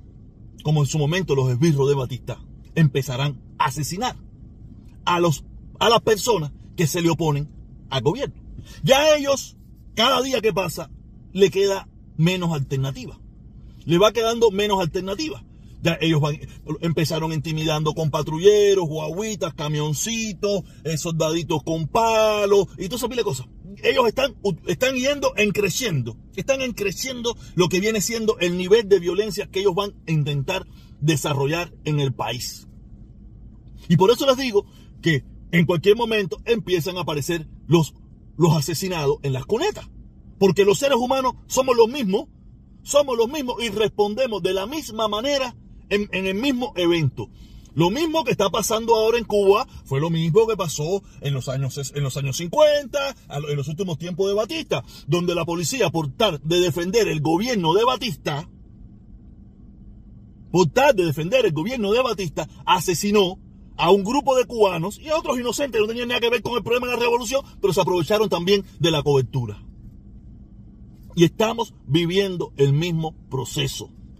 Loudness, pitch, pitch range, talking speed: -21 LUFS, 180 Hz, 150-220 Hz, 160 wpm